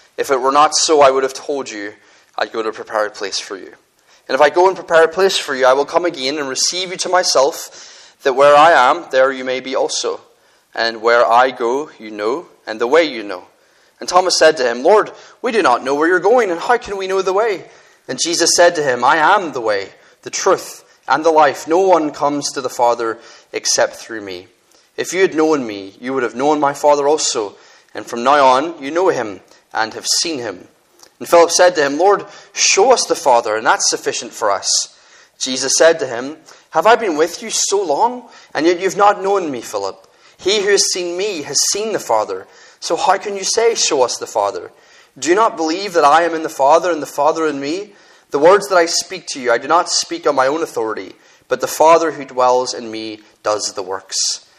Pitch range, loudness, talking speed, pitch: 140-230 Hz, -15 LUFS, 235 wpm, 170 Hz